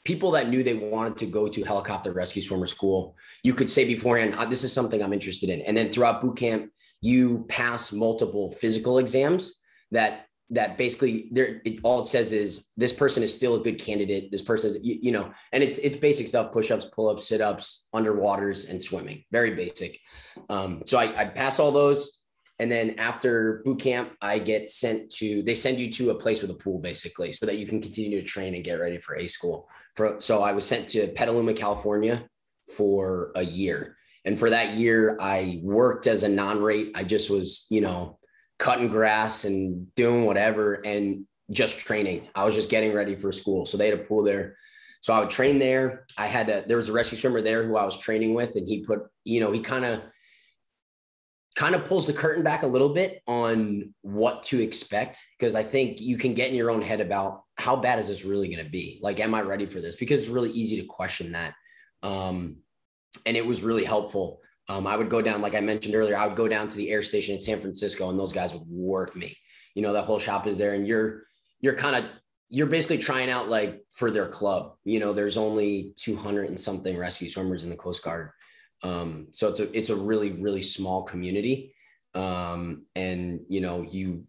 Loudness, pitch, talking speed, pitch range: -26 LUFS, 105 Hz, 220 wpm, 100-120 Hz